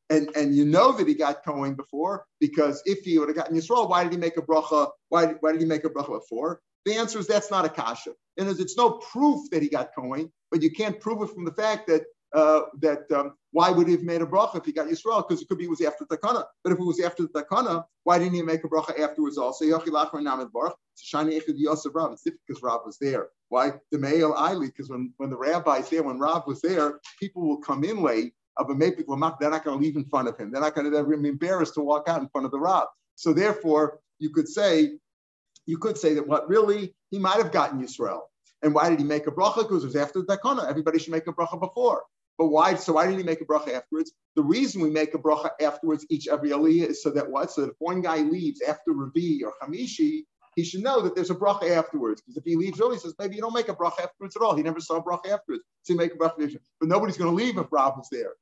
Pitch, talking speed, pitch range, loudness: 165 Hz, 270 wpm, 150-195 Hz, -25 LUFS